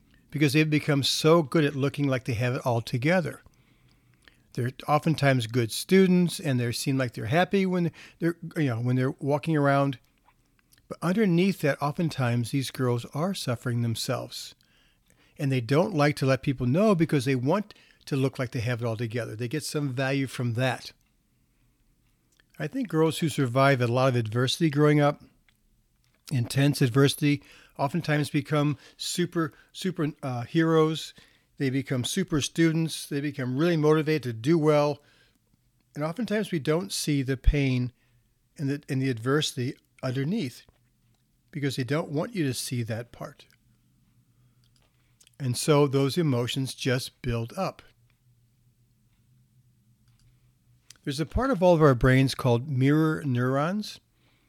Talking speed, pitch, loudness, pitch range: 150 wpm, 140 Hz, -26 LUFS, 125-155 Hz